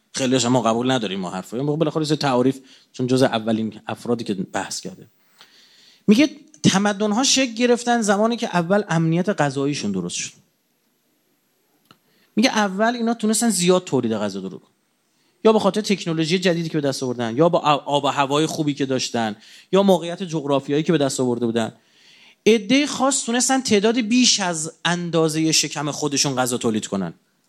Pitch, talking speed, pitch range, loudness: 160 Hz, 160 wpm, 130-210 Hz, -20 LUFS